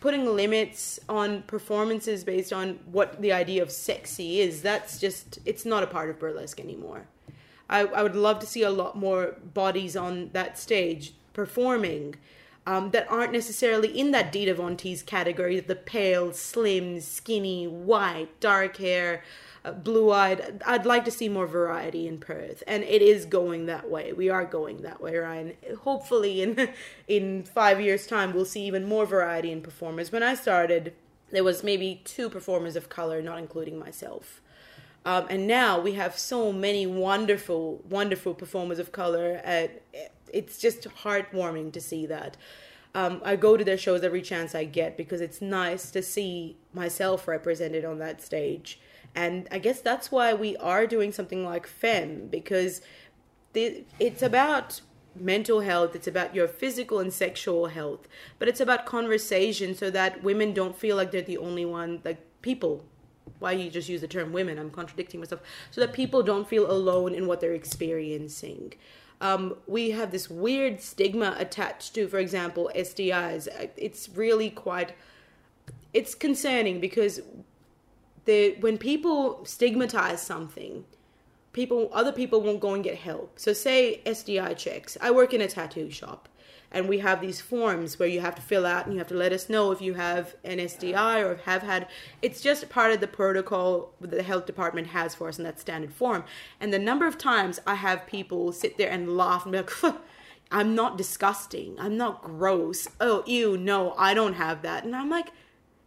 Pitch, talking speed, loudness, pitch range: 190 Hz, 175 wpm, -27 LUFS, 175-215 Hz